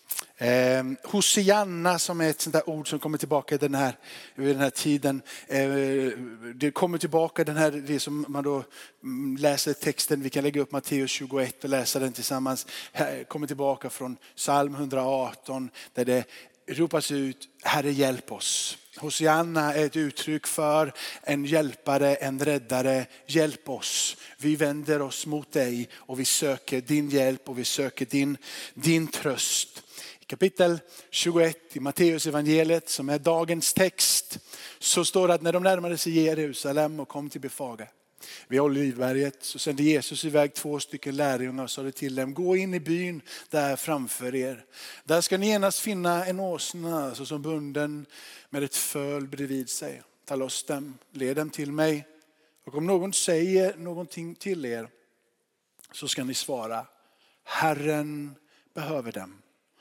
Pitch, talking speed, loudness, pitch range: 145 Hz, 155 wpm, -27 LUFS, 135-160 Hz